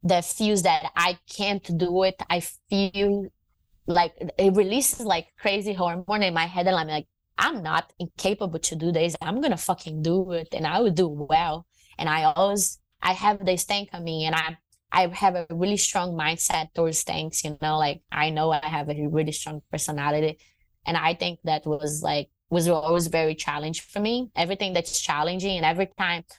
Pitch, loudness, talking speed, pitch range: 170 Hz, -25 LUFS, 195 wpm, 155-190 Hz